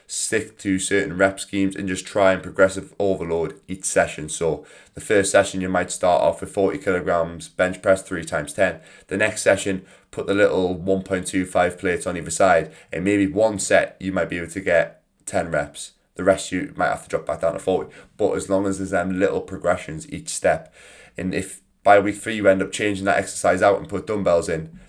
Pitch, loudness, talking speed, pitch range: 95 Hz, -22 LUFS, 215 wpm, 95-100 Hz